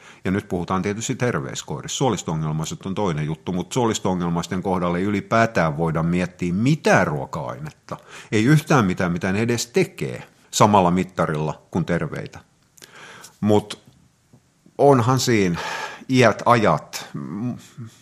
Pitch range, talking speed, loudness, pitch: 90-130 Hz, 115 wpm, -21 LUFS, 100 Hz